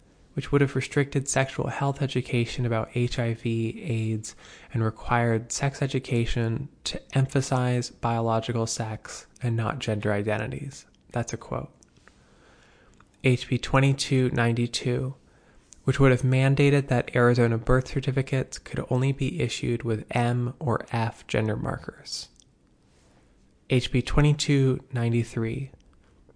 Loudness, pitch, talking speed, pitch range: -26 LUFS, 125 Hz, 105 wpm, 115-135 Hz